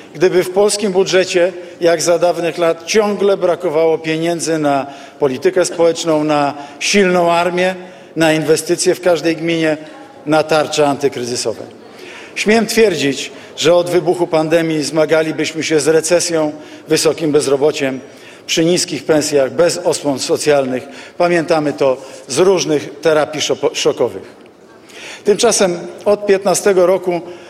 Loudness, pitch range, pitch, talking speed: -14 LUFS, 150-180 Hz, 165 Hz, 115 wpm